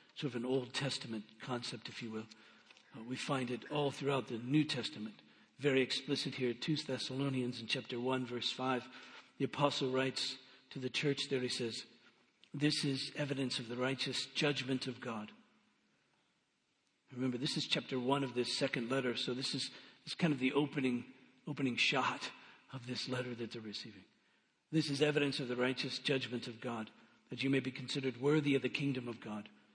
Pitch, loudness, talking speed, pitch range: 130 Hz, -37 LUFS, 185 wpm, 125-140 Hz